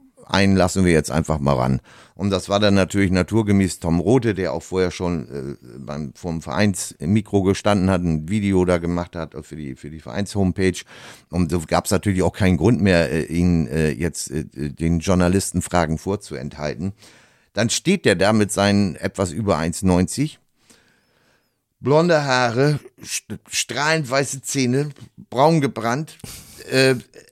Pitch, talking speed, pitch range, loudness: 95 Hz, 160 wpm, 85-105 Hz, -20 LUFS